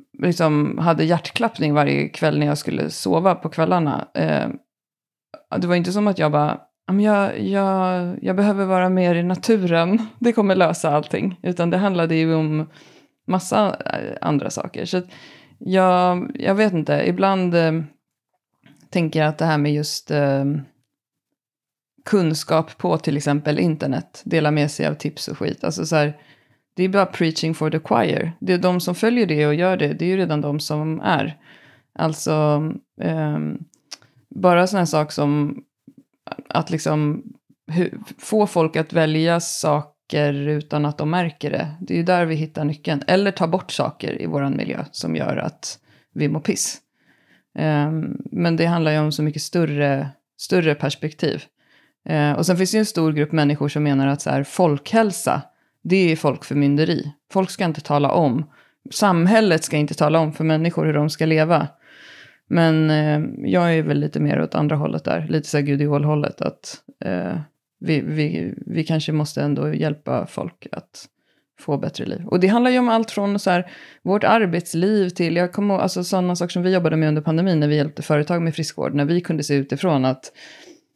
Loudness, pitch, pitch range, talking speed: -20 LUFS, 160 Hz, 150-185 Hz, 175 wpm